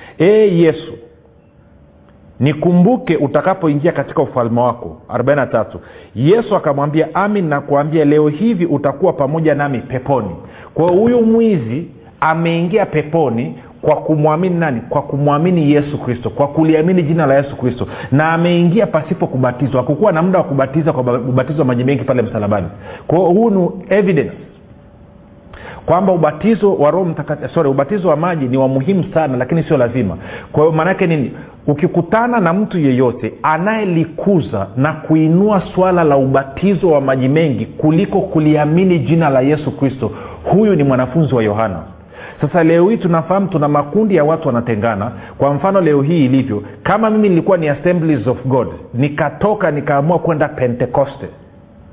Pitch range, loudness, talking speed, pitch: 130-175 Hz, -14 LUFS, 140 wpm, 155 Hz